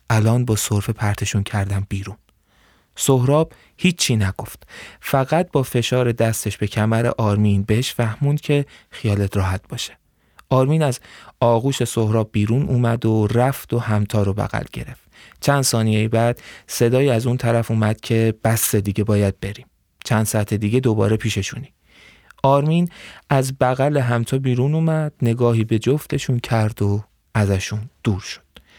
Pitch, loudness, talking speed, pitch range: 115 Hz, -20 LUFS, 140 wpm, 105-130 Hz